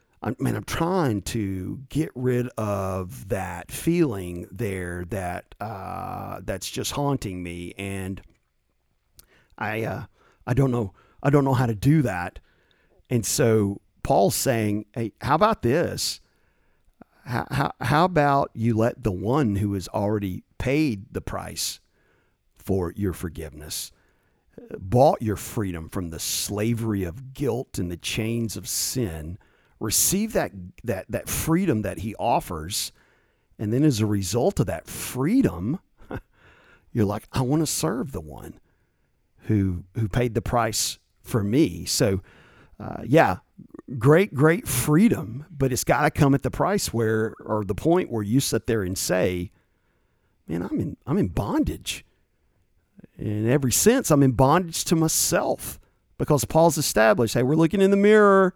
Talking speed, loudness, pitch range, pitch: 150 wpm, -24 LUFS, 95-135 Hz, 115 Hz